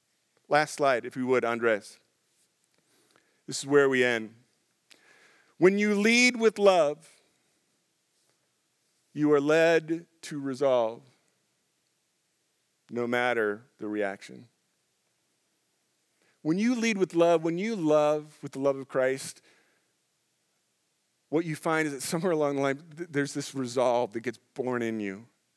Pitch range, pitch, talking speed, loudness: 125-165 Hz, 140 Hz, 130 wpm, -27 LUFS